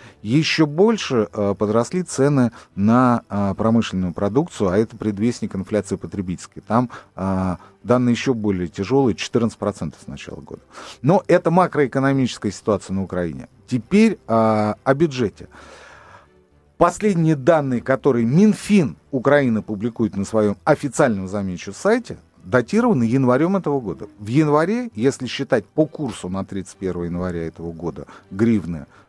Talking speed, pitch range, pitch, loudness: 120 wpm, 95-140 Hz, 115 Hz, -20 LUFS